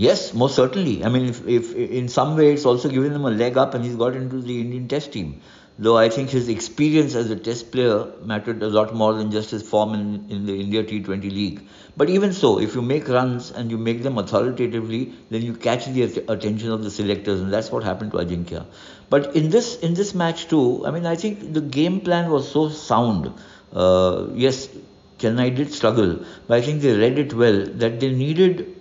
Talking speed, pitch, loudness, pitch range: 225 wpm, 120 Hz, -21 LUFS, 110-145 Hz